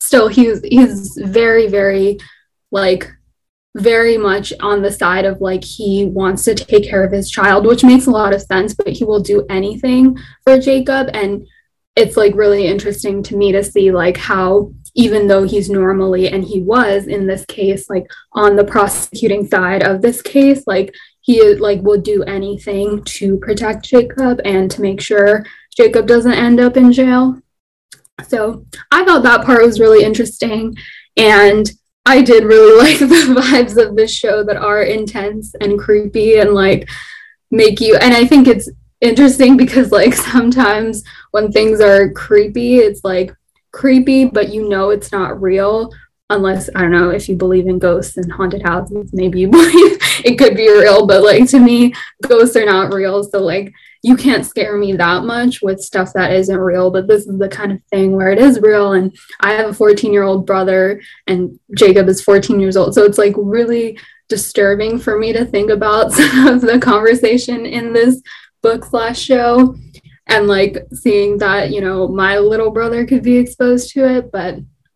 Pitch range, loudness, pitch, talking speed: 195-240 Hz, -11 LUFS, 210 Hz, 185 wpm